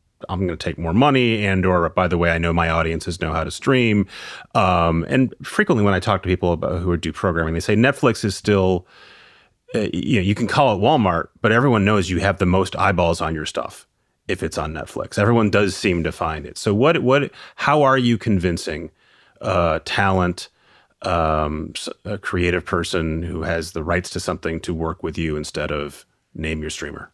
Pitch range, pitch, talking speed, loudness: 85-105 Hz, 90 Hz, 210 wpm, -20 LUFS